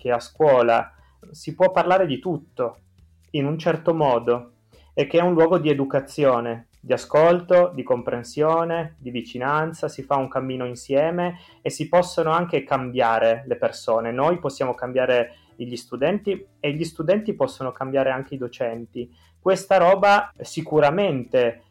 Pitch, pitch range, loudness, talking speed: 140 Hz, 120-165 Hz, -22 LUFS, 145 wpm